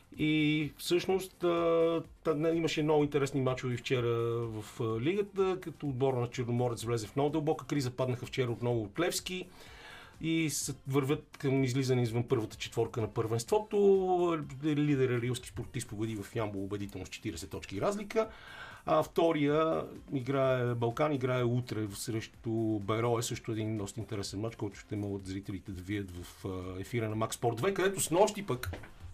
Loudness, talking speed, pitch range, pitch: -33 LUFS, 150 wpm, 110-155 Hz, 125 Hz